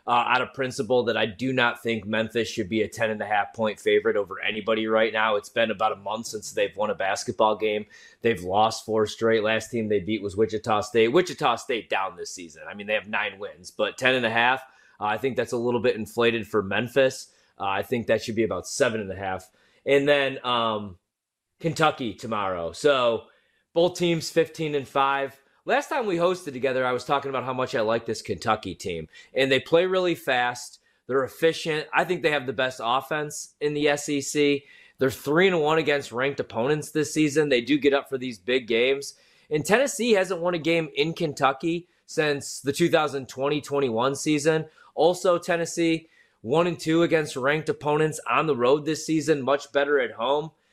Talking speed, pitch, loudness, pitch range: 205 wpm, 135 Hz, -25 LUFS, 115-155 Hz